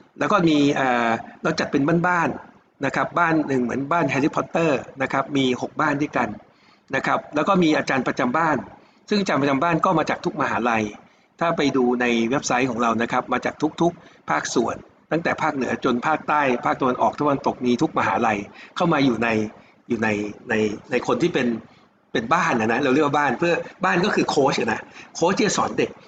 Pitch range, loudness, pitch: 120-160 Hz, -22 LUFS, 135 Hz